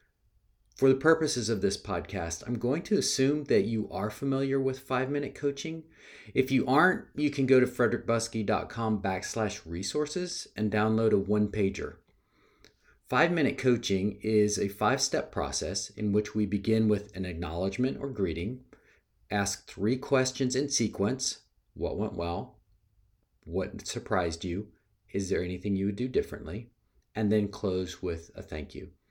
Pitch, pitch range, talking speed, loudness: 110 Hz, 100-130 Hz, 150 wpm, -29 LUFS